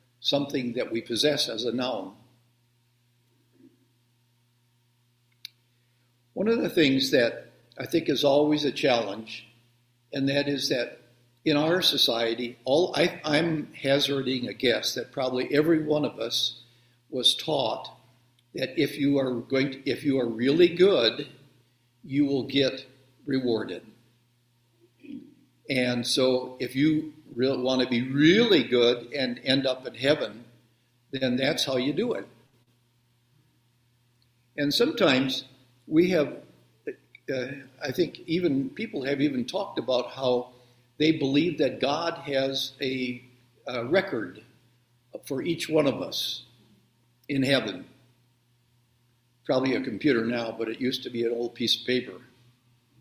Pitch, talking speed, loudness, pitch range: 125 Hz, 135 wpm, -26 LUFS, 120-140 Hz